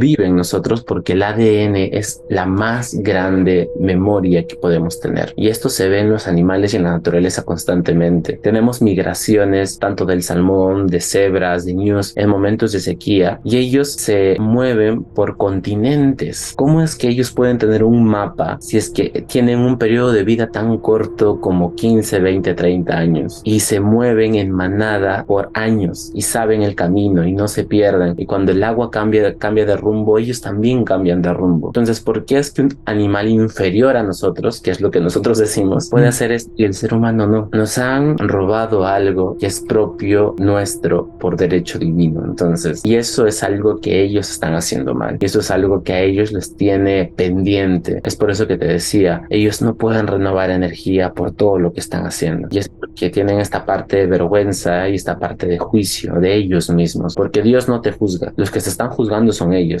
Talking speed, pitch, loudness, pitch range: 195 wpm, 100 Hz, -15 LUFS, 90-110 Hz